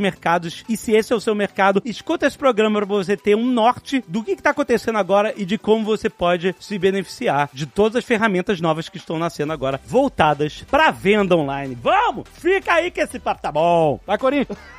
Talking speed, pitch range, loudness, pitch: 210 wpm, 175-240 Hz, -19 LUFS, 205 Hz